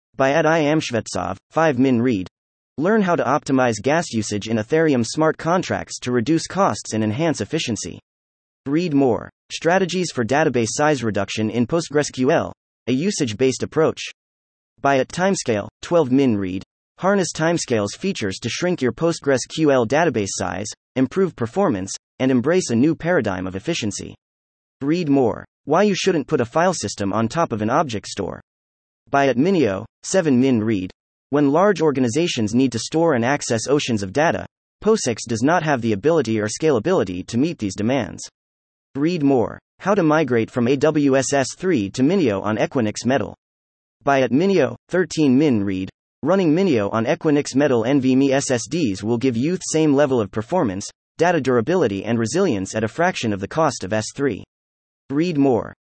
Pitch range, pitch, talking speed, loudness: 105-155 Hz, 130 Hz, 165 wpm, -20 LUFS